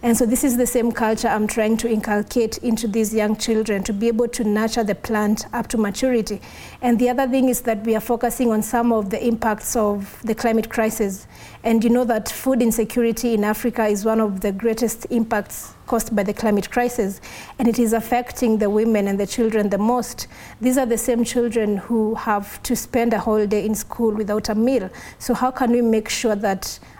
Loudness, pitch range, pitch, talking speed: -20 LUFS, 215-240 Hz, 225 Hz, 215 wpm